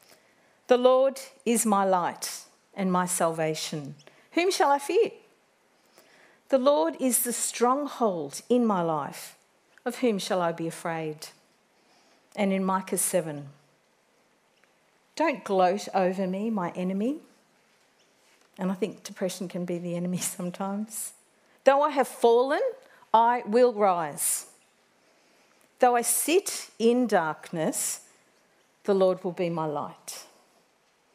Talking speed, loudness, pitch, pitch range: 120 wpm, -26 LUFS, 200 Hz, 180-250 Hz